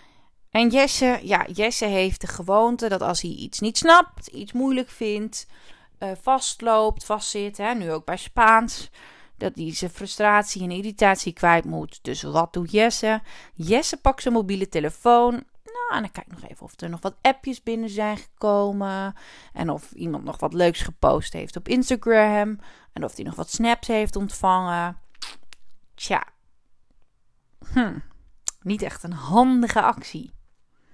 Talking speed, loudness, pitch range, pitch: 155 wpm, -22 LUFS, 190-235 Hz, 215 Hz